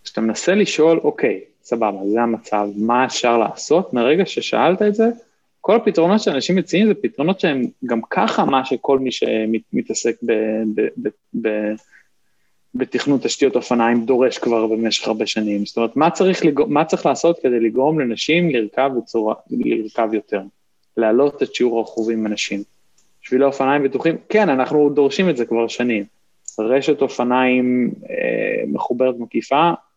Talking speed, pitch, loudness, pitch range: 140 wpm, 130 Hz, -18 LUFS, 115-165 Hz